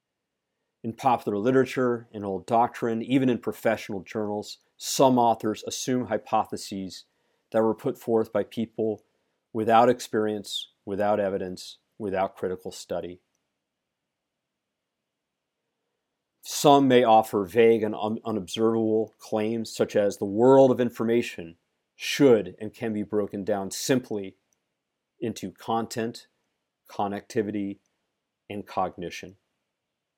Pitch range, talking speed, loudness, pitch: 105-120 Hz, 105 wpm, -25 LUFS, 110 Hz